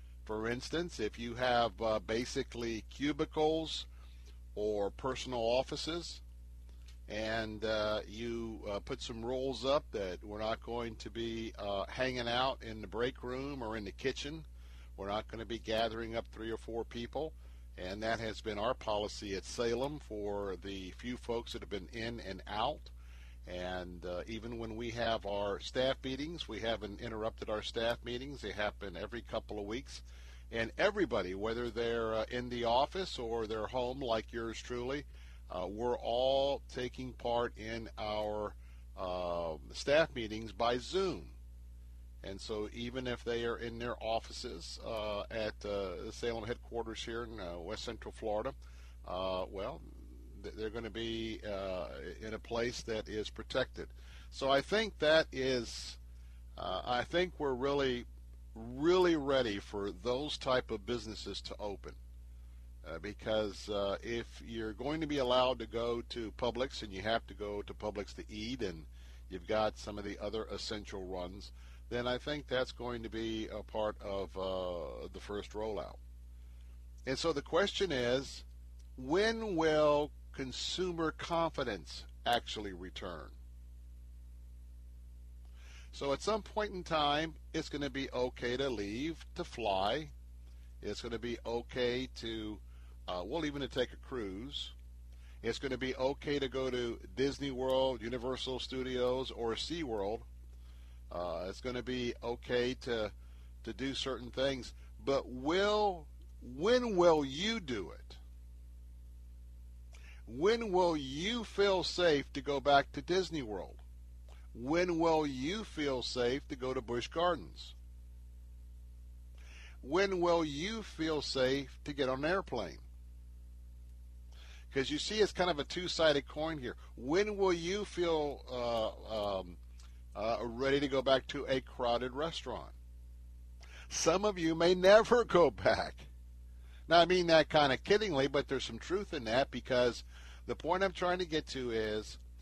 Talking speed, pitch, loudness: 155 wpm, 115 Hz, -36 LUFS